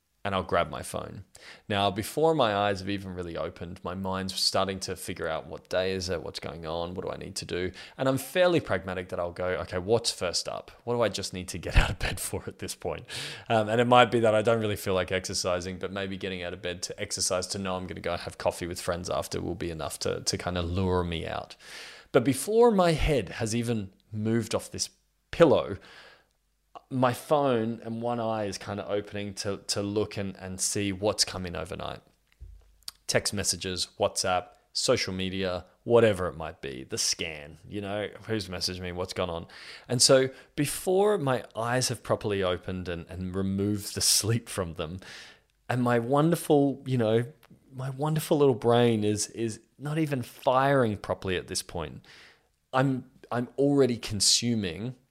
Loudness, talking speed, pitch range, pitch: -28 LUFS, 195 wpm, 90-120 Hz, 100 Hz